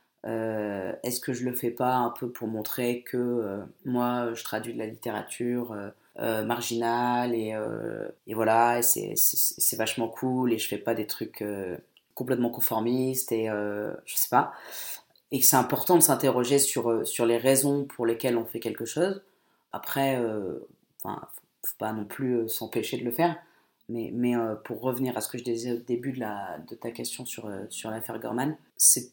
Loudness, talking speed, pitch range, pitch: -27 LUFS, 195 wpm, 110-125 Hz, 120 Hz